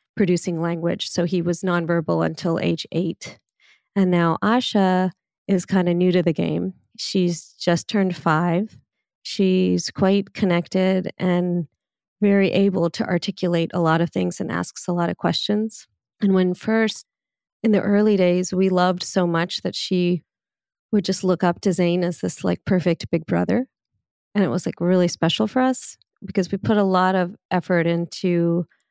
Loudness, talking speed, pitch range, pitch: -21 LUFS, 170 wpm, 175-195 Hz, 180 Hz